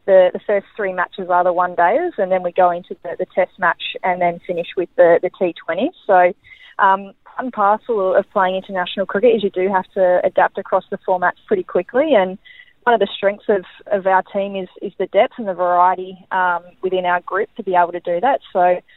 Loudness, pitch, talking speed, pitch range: -18 LUFS, 190 Hz, 220 wpm, 180-205 Hz